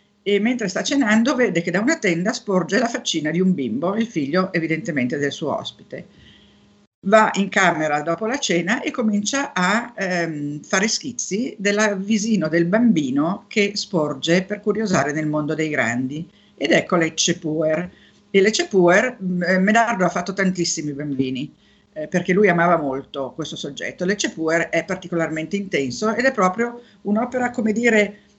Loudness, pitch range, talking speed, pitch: -20 LUFS, 165-215 Hz, 160 wpm, 185 Hz